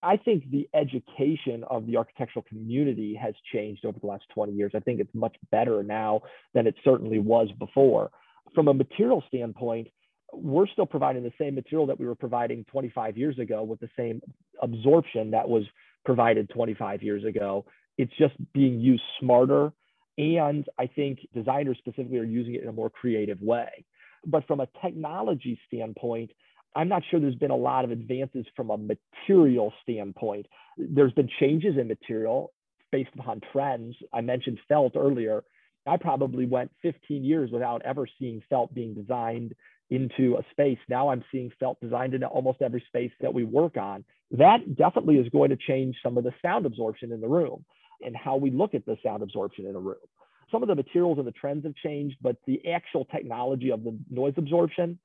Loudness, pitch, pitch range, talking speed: -27 LUFS, 130 Hz, 115-145 Hz, 185 wpm